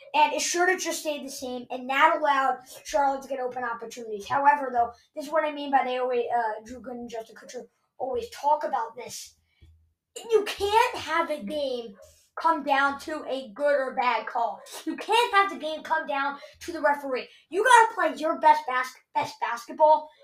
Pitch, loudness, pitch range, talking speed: 285 Hz, -25 LUFS, 250-315 Hz, 200 wpm